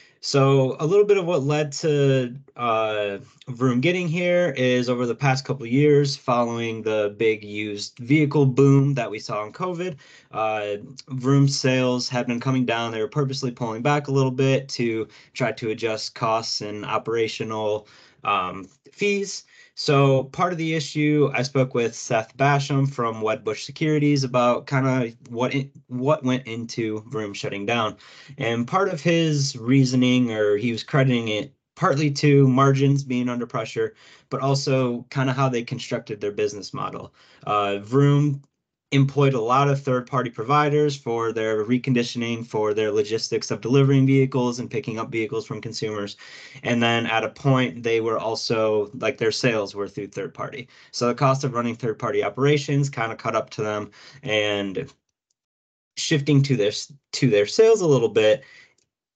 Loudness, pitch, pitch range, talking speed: -22 LUFS, 130 Hz, 115-140 Hz, 170 wpm